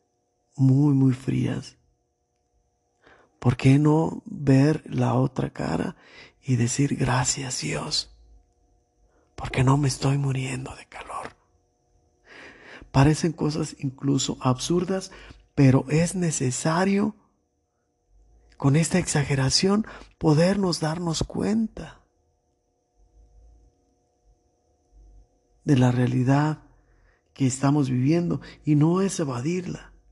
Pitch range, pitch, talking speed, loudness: 125-160 Hz, 140 Hz, 90 wpm, -23 LUFS